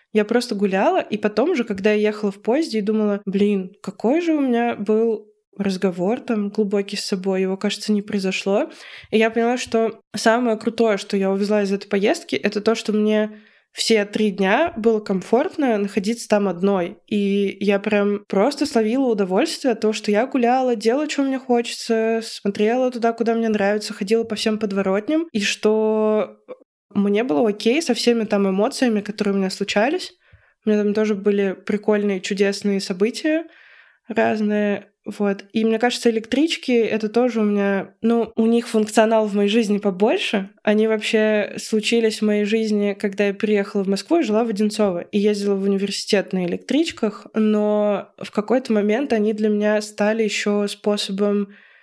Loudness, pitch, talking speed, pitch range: -20 LUFS, 215 Hz, 170 wpm, 205-230 Hz